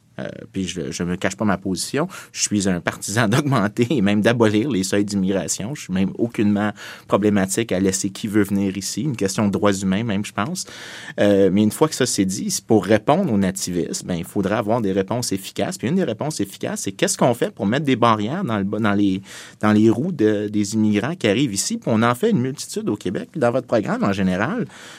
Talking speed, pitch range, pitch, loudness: 235 wpm, 95-115 Hz, 105 Hz, -20 LUFS